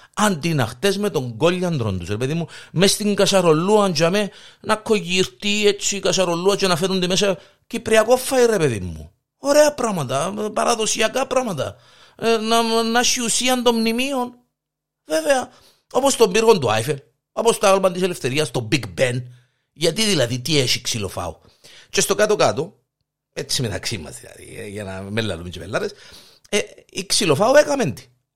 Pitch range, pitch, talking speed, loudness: 140-225 Hz, 195 Hz, 155 wpm, -19 LUFS